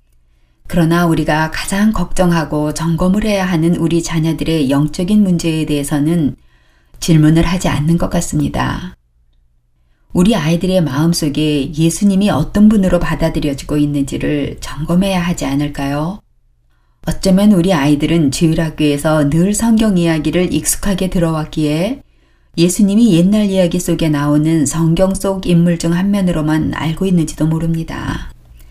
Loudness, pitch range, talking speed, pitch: -14 LUFS, 150-180 Hz, 320 characters per minute, 165 Hz